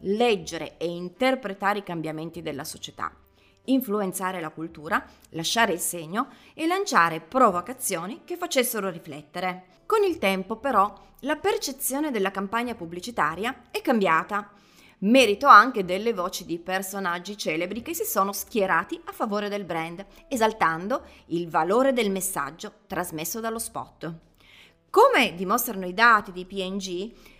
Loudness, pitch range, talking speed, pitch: -25 LUFS, 175-245 Hz, 130 wpm, 200 Hz